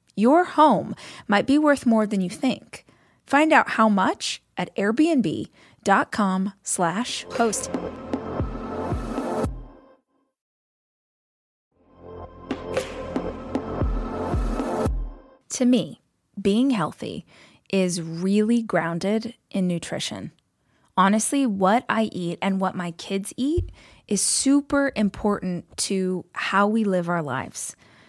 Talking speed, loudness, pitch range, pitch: 95 wpm, -23 LUFS, 185-255 Hz, 205 Hz